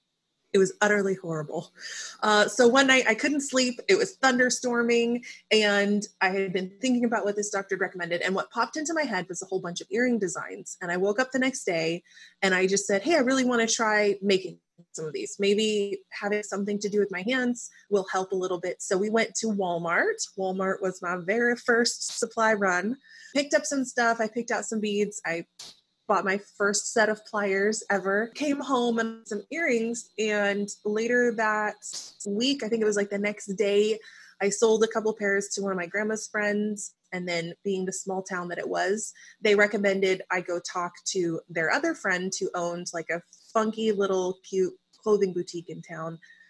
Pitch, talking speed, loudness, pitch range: 205 Hz, 205 wpm, -26 LUFS, 190-230 Hz